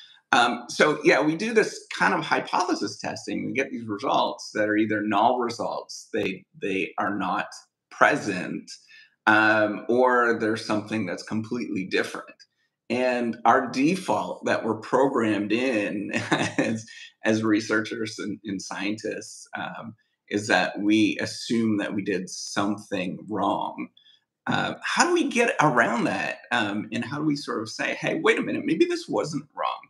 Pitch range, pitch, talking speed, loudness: 110-170 Hz, 115 Hz, 155 wpm, -25 LUFS